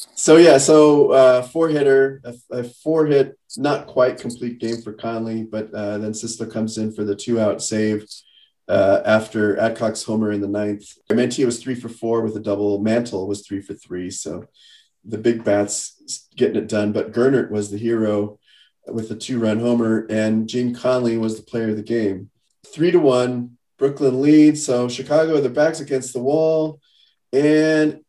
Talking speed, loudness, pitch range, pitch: 185 wpm, -19 LUFS, 110-135 Hz, 115 Hz